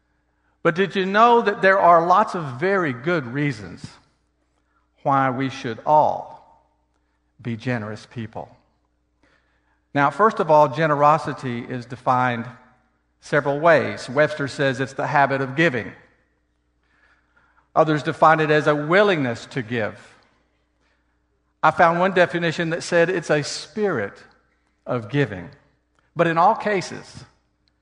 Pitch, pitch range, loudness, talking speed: 140 Hz, 115-165 Hz, -20 LUFS, 125 wpm